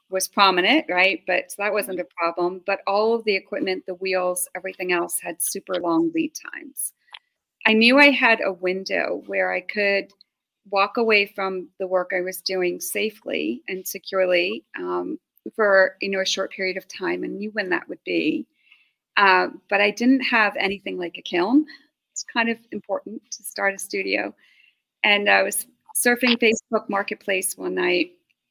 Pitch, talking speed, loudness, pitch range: 200 Hz, 175 wpm, -22 LUFS, 185-245 Hz